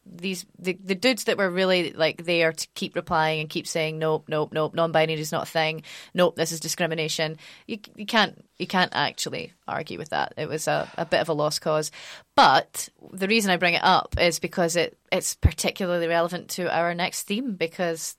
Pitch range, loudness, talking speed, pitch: 160-185 Hz, -24 LUFS, 210 wpm, 170 Hz